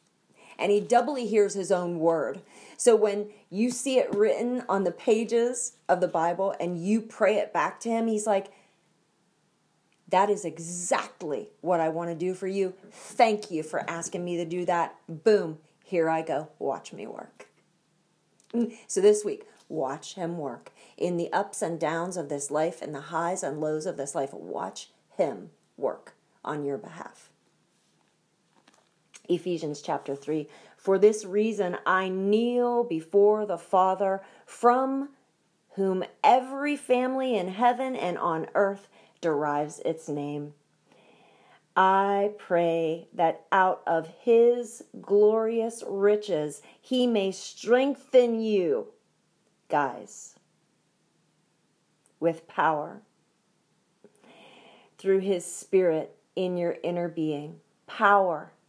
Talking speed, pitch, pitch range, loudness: 130 wpm, 190 Hz, 170-225 Hz, -27 LUFS